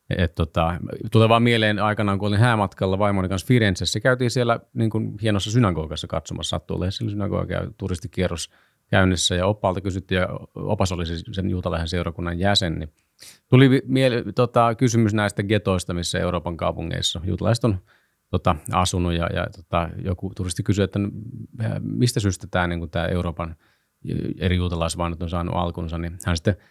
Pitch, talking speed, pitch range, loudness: 95 Hz, 150 wpm, 85-110 Hz, -23 LUFS